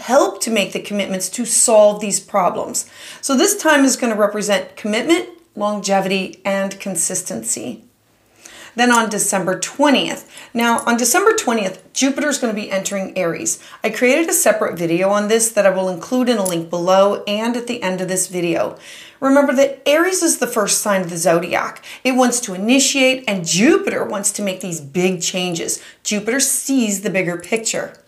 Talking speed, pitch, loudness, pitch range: 180 wpm, 210 Hz, -17 LUFS, 190-255 Hz